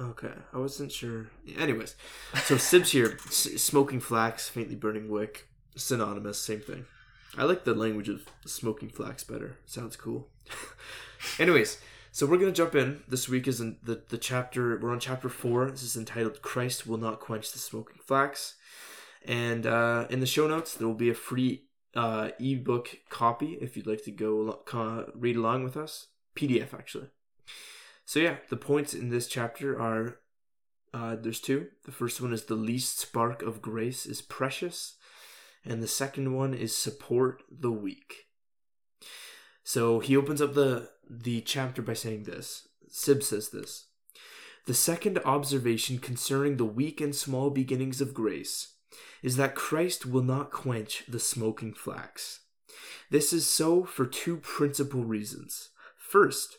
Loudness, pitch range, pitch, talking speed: -30 LUFS, 115-140 Hz, 125 Hz, 160 wpm